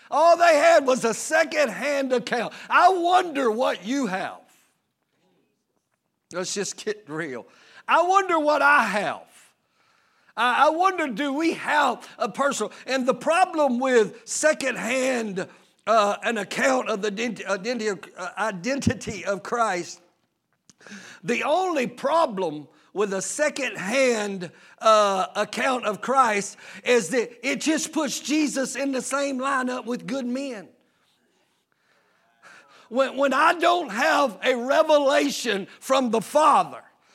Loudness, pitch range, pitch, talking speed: -23 LUFS, 220-295 Hz, 260 Hz, 120 wpm